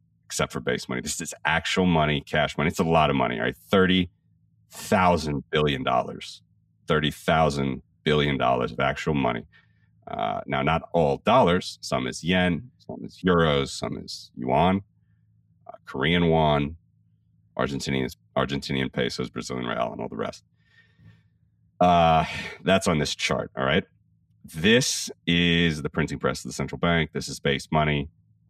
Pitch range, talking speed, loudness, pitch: 70-90 Hz, 155 wpm, -24 LUFS, 80 Hz